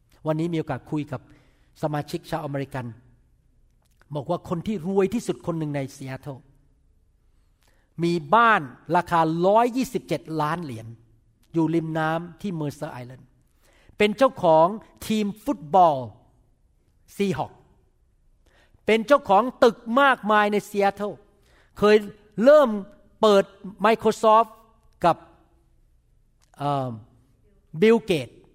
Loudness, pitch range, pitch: -22 LUFS, 130-205 Hz, 165 Hz